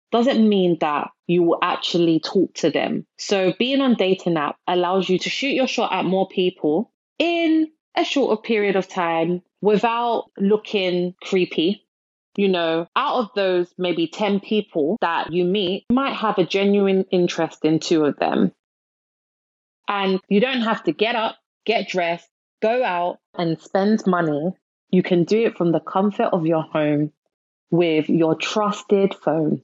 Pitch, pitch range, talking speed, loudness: 190 Hz, 175-215 Hz, 165 wpm, -21 LUFS